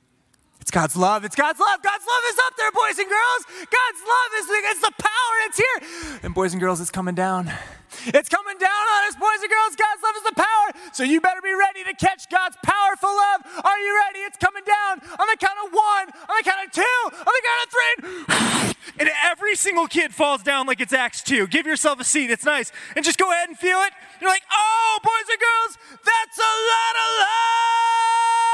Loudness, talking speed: -20 LUFS, 225 wpm